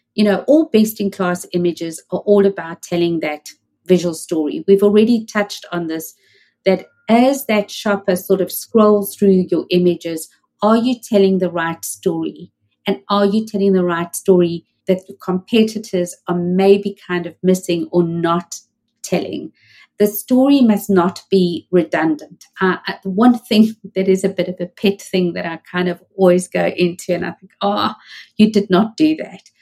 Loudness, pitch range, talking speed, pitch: -17 LUFS, 175-205 Hz, 175 wpm, 185 Hz